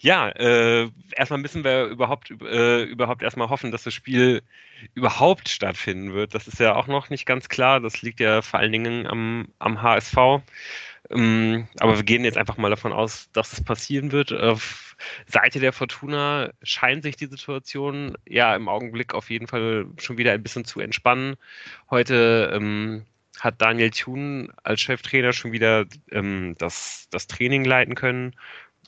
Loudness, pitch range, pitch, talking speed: -22 LUFS, 110-130 Hz, 120 Hz, 170 wpm